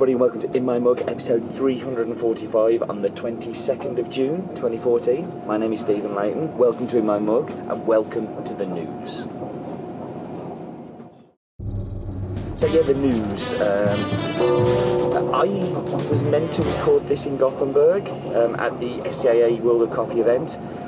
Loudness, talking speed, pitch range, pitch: -22 LUFS, 145 wpm, 105-125 Hz, 115 Hz